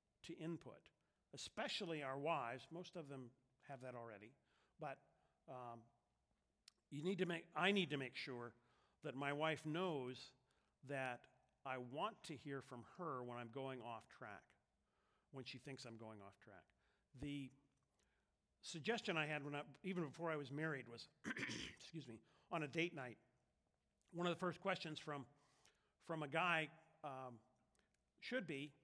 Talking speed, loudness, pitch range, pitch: 150 wpm, -48 LUFS, 125-160 Hz, 140 Hz